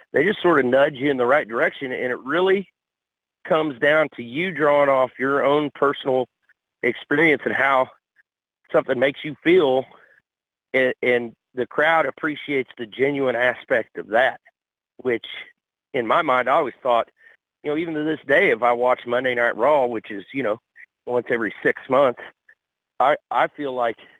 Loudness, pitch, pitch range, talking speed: -21 LUFS, 140 Hz, 125-155 Hz, 175 wpm